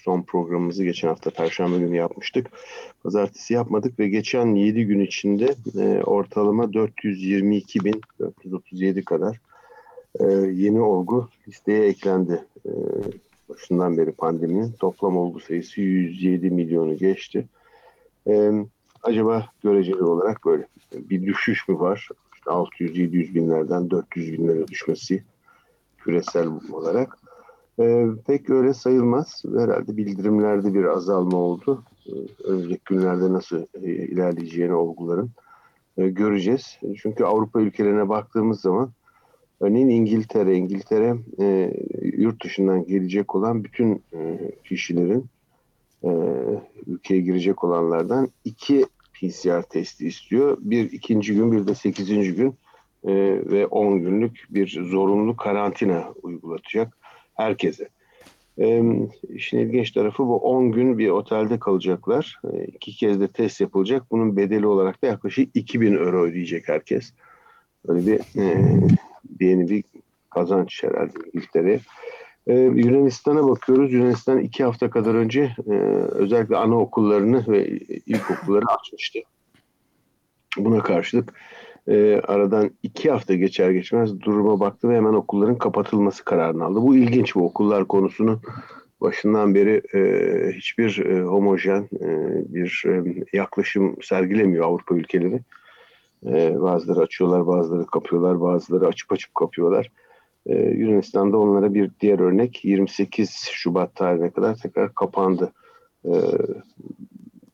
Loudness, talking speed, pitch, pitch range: -21 LUFS, 120 wpm, 105 Hz, 95-120 Hz